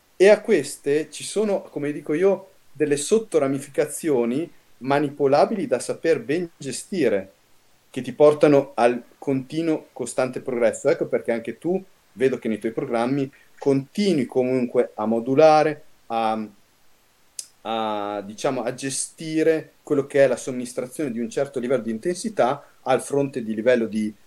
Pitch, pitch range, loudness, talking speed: 140 Hz, 120-155 Hz, -23 LUFS, 140 wpm